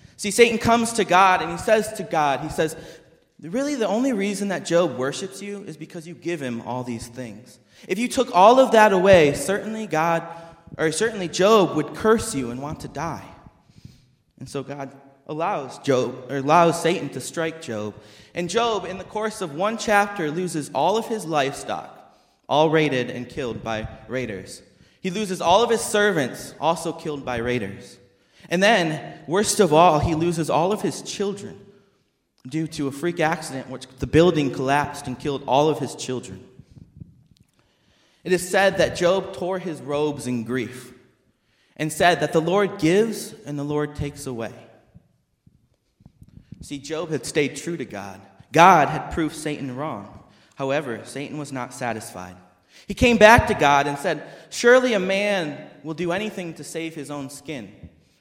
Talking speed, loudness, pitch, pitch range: 175 wpm, -21 LUFS, 155 Hz, 135-190 Hz